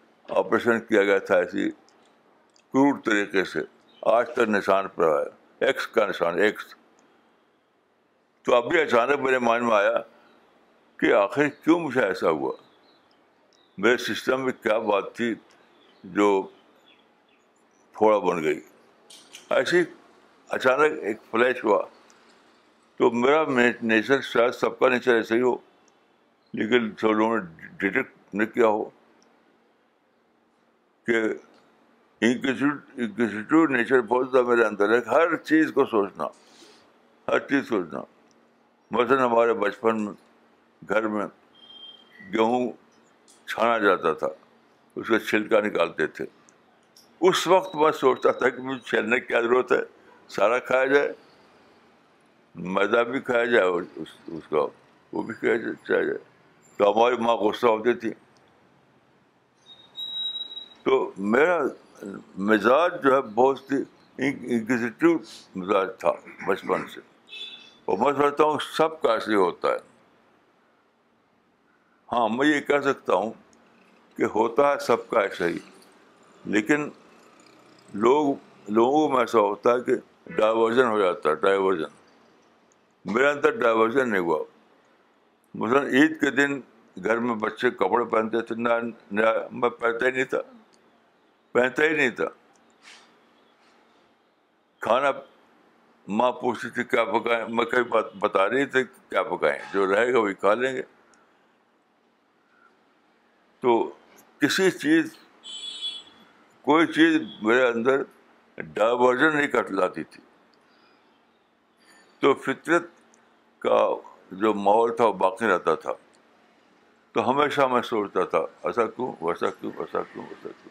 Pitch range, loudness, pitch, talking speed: 115-160 Hz, -24 LUFS, 130 Hz, 125 wpm